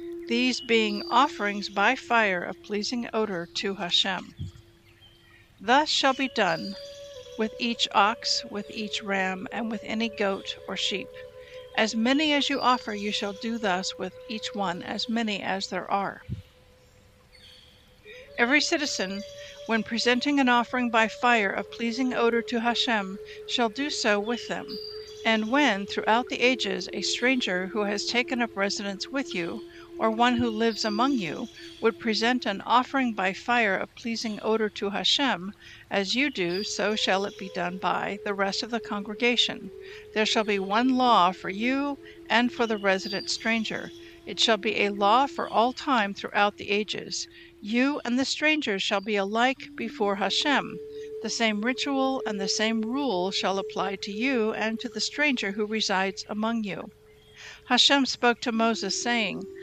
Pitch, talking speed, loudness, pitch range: 225 Hz, 165 wpm, -26 LUFS, 200-250 Hz